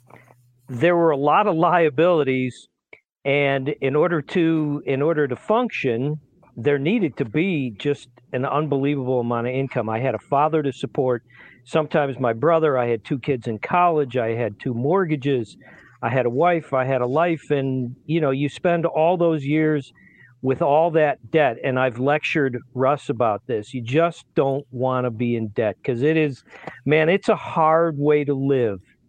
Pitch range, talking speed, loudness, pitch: 125-160 Hz, 180 wpm, -21 LUFS, 140 Hz